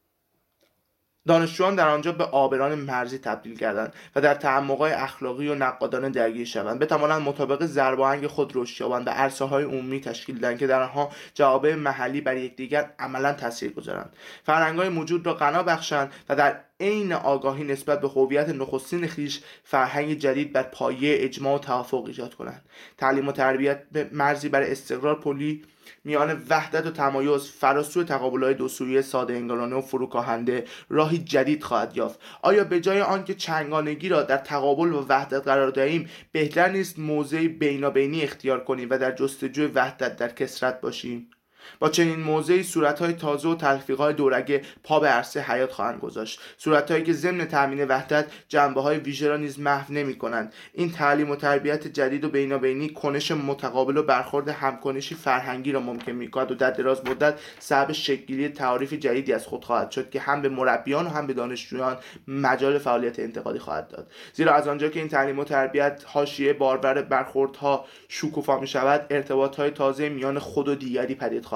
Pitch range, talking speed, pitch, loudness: 130-150 Hz, 175 wpm, 140 Hz, -25 LUFS